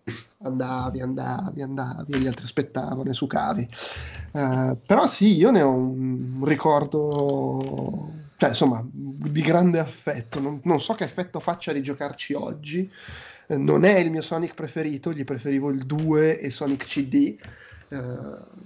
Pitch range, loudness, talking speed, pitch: 130-165 Hz, -24 LUFS, 150 wpm, 145 Hz